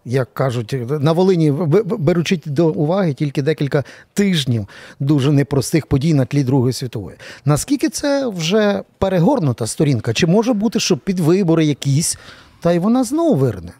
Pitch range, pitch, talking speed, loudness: 135-190 Hz, 155 Hz, 150 wpm, -17 LUFS